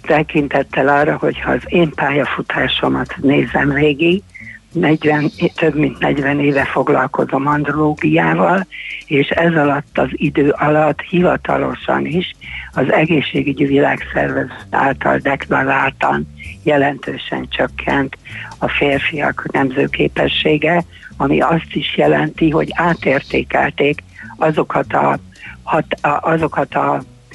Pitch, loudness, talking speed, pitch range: 145 Hz, -16 LUFS, 105 wpm, 140-155 Hz